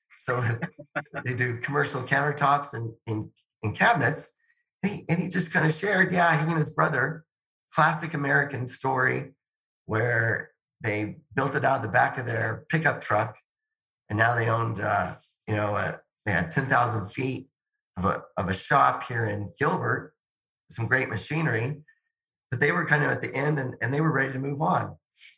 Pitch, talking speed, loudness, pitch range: 135 Hz, 180 wpm, -26 LUFS, 115-160 Hz